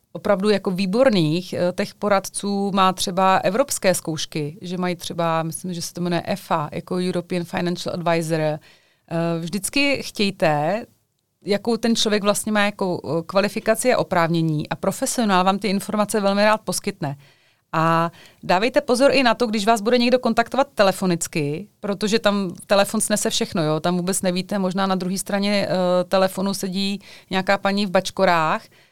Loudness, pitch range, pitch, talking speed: -21 LUFS, 175-210 Hz, 190 Hz, 150 wpm